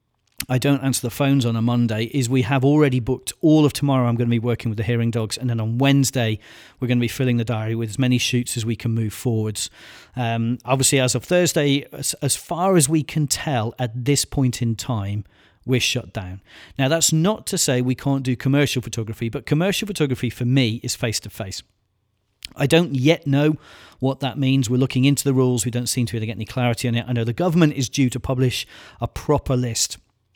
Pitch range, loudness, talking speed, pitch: 115-140 Hz, -21 LUFS, 235 wpm, 125 Hz